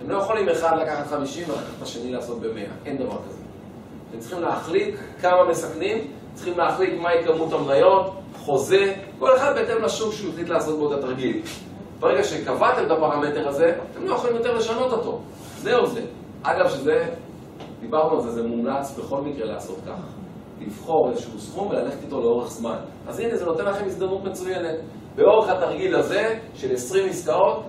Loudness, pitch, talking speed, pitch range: -23 LUFS, 170 Hz, 170 wpm, 145-215 Hz